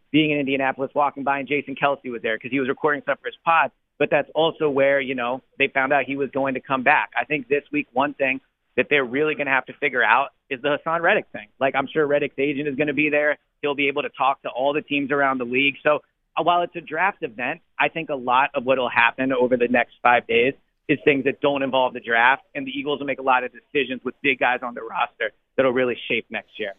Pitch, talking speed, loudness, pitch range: 140 Hz, 270 wpm, -22 LUFS, 130-145 Hz